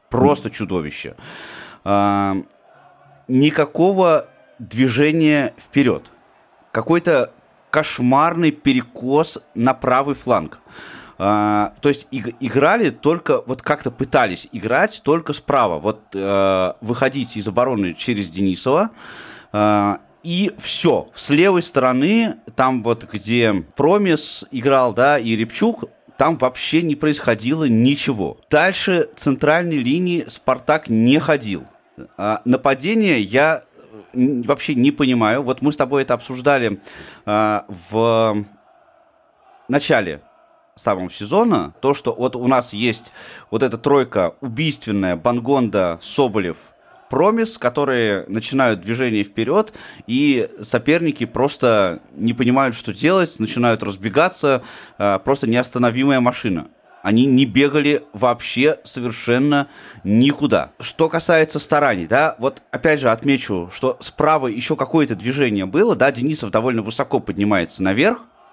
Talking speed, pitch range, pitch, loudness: 110 wpm, 110-145 Hz, 130 Hz, -18 LUFS